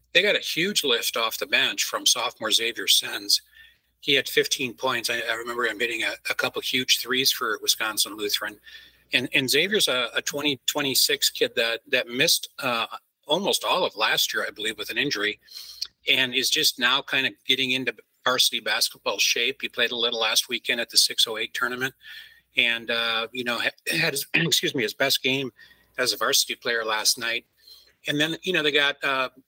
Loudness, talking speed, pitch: -23 LUFS, 195 wpm, 155 Hz